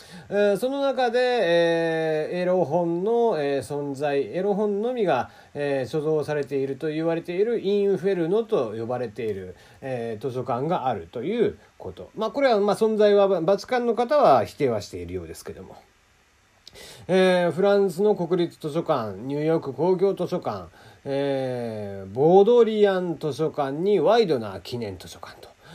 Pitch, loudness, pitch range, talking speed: 170 Hz, -23 LUFS, 140-200 Hz, 295 characters per minute